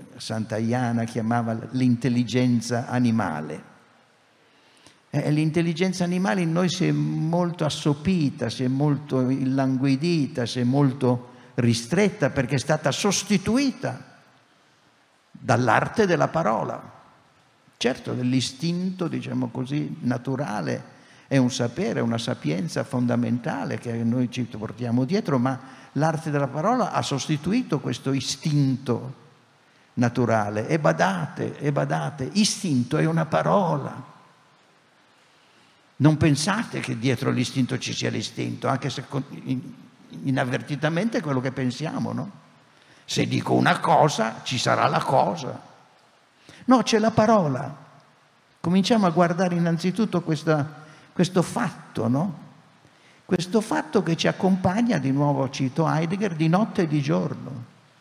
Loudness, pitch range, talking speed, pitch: -24 LUFS, 125-175 Hz, 115 wpm, 140 Hz